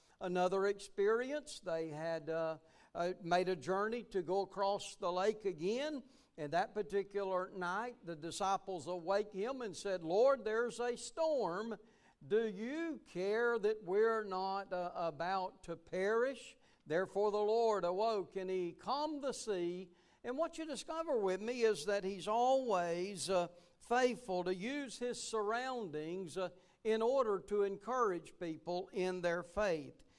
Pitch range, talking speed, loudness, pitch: 180-230 Hz, 145 wpm, -38 LUFS, 200 Hz